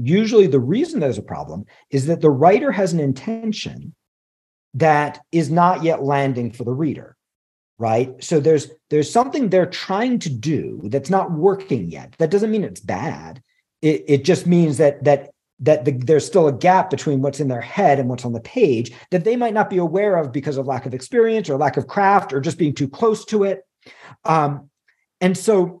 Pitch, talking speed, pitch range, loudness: 160 Hz, 200 wpm, 140-195 Hz, -19 LUFS